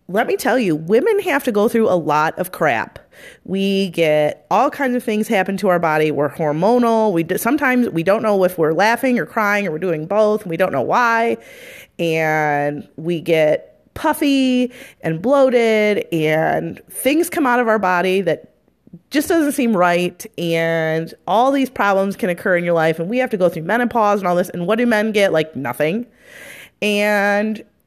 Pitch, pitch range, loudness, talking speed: 205 Hz, 170-245 Hz, -17 LUFS, 195 wpm